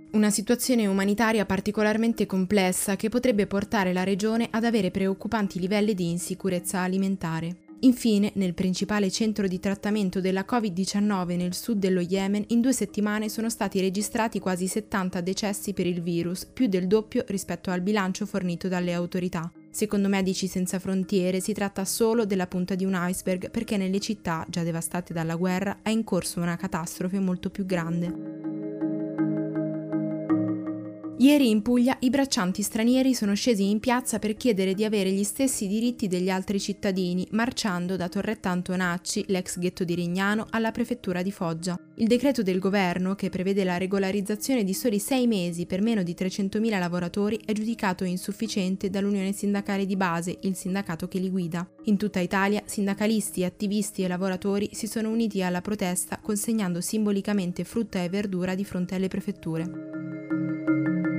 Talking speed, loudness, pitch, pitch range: 155 wpm, -26 LUFS, 195 Hz, 180-215 Hz